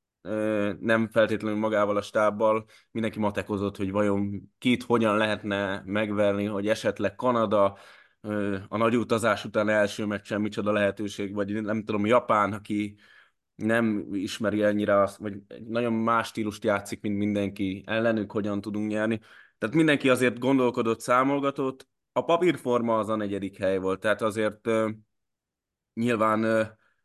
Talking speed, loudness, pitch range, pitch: 130 wpm, -26 LUFS, 100-115 Hz, 105 Hz